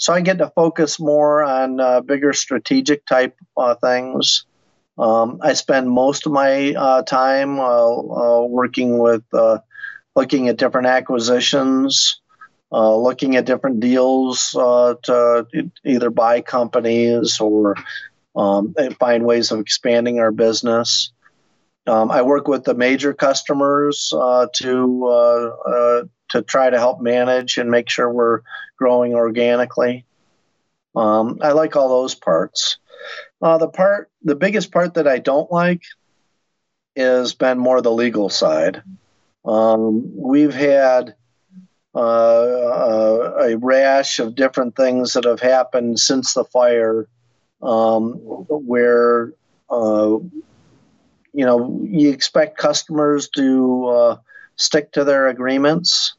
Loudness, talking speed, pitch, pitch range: -16 LUFS, 130 wpm, 125 Hz, 120-145 Hz